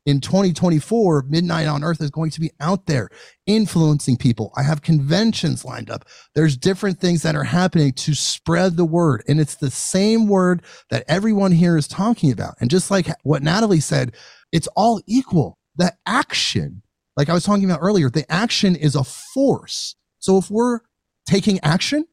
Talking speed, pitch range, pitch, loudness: 180 wpm, 150-195 Hz, 165 Hz, -19 LUFS